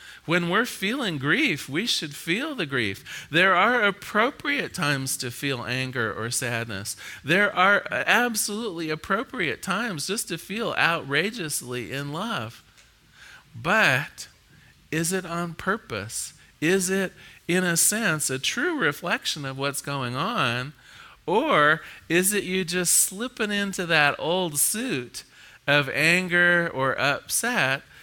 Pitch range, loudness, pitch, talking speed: 140-195 Hz, -24 LUFS, 170 Hz, 130 wpm